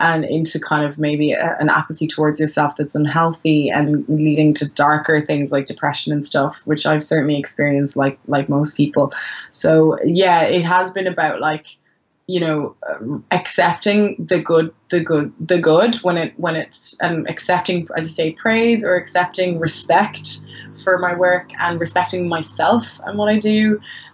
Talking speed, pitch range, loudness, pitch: 175 wpm, 150-180 Hz, -17 LUFS, 160 Hz